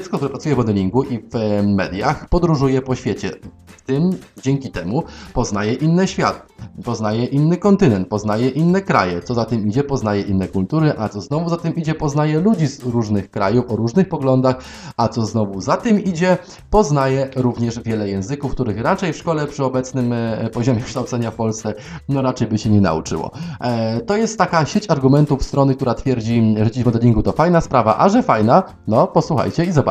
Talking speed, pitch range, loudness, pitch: 190 wpm, 110-155 Hz, -18 LUFS, 130 Hz